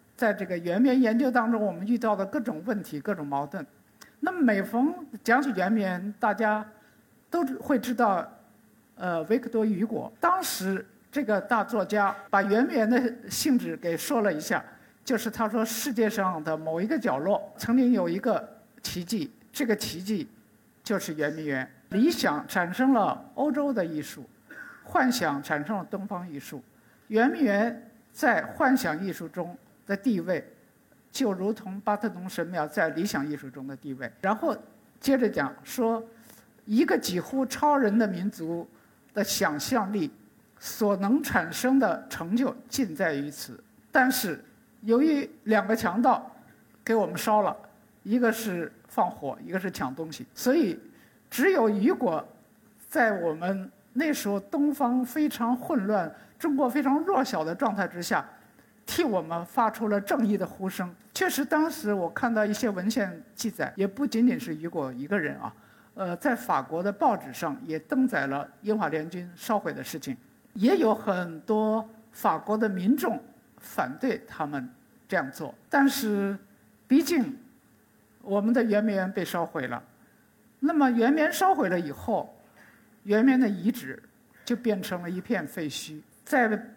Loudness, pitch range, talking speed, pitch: -27 LUFS, 190-255 Hz, 230 characters per minute, 220 Hz